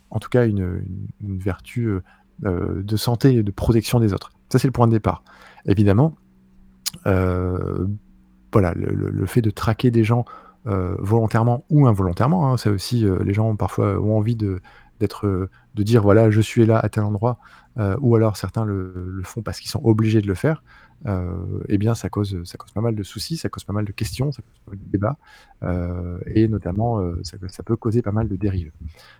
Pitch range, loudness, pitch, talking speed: 95-115 Hz, -21 LUFS, 105 Hz, 215 wpm